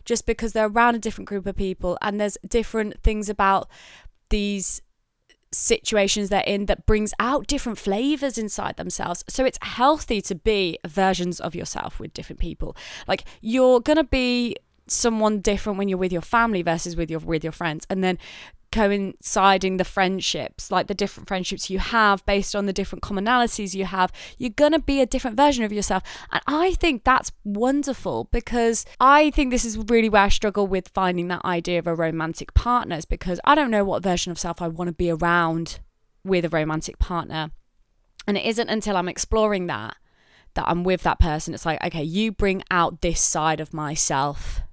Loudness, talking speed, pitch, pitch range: -22 LUFS, 190 wpm, 200 Hz, 175-230 Hz